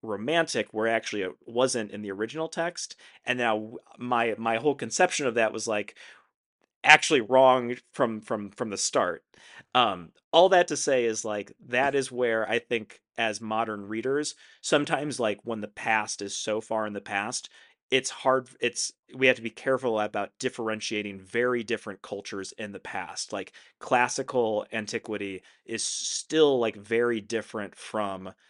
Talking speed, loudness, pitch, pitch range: 160 wpm, -27 LUFS, 115 Hz, 105-125 Hz